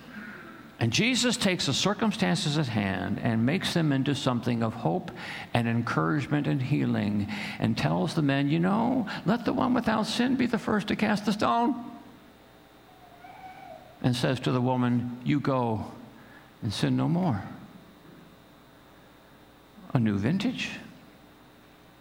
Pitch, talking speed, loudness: 145 Hz, 135 wpm, -27 LUFS